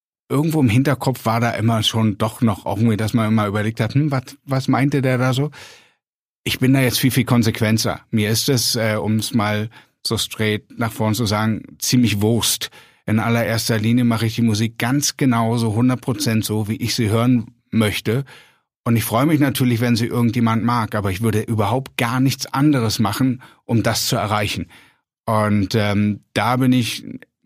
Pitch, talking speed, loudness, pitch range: 115 Hz, 190 wpm, -19 LUFS, 110-130 Hz